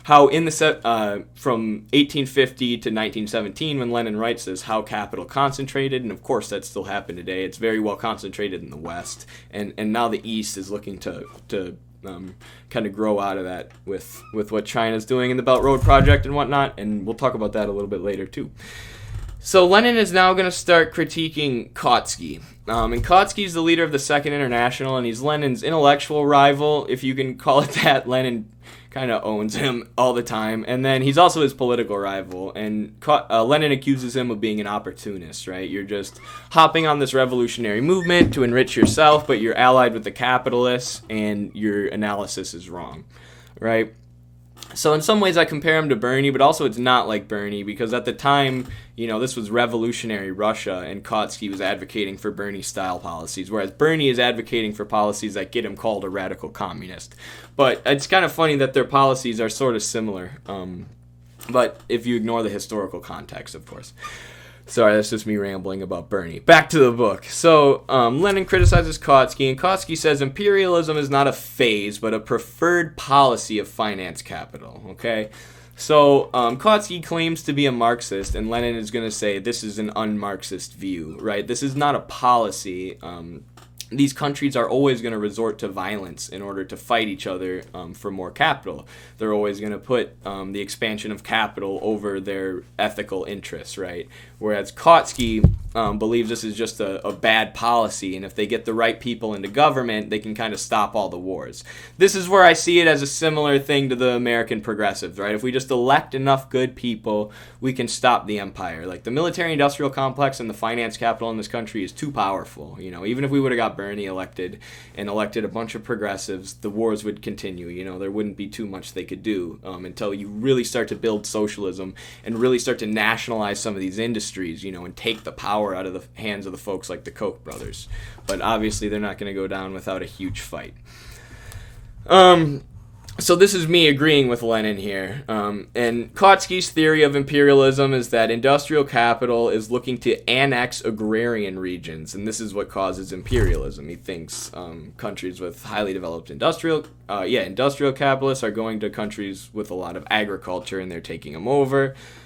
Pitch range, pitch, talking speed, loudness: 100-135 Hz, 115 Hz, 200 wpm, -21 LUFS